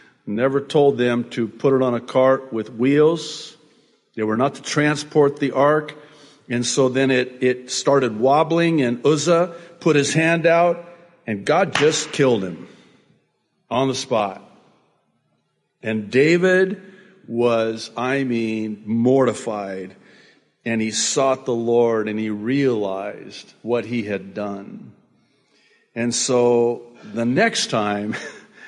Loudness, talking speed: -20 LUFS, 130 wpm